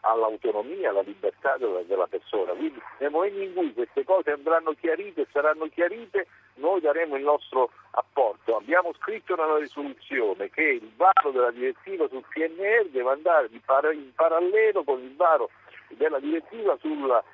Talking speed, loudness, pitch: 160 wpm, -25 LUFS, 310 Hz